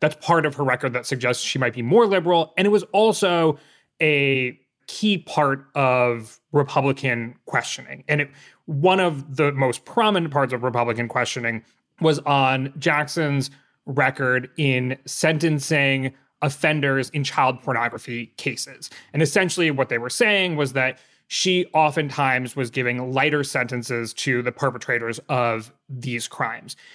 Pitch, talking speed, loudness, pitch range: 140 Hz, 145 wpm, -21 LUFS, 125-155 Hz